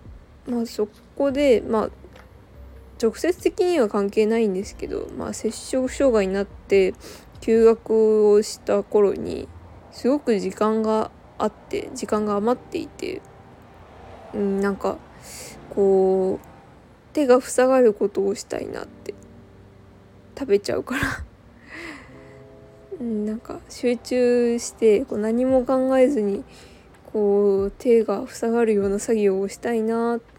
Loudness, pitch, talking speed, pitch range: -22 LUFS, 225 Hz, 225 characters per minute, 210-255 Hz